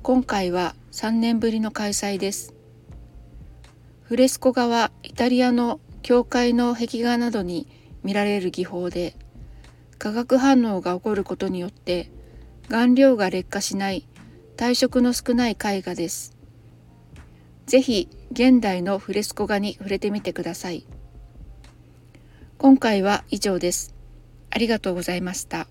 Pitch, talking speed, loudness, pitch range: 205 Hz, 250 characters per minute, -22 LUFS, 180-240 Hz